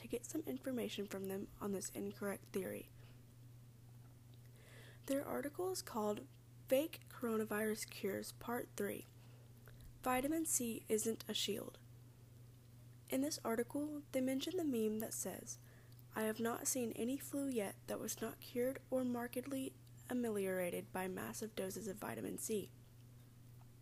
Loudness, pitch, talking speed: -42 LUFS, 200 Hz, 135 wpm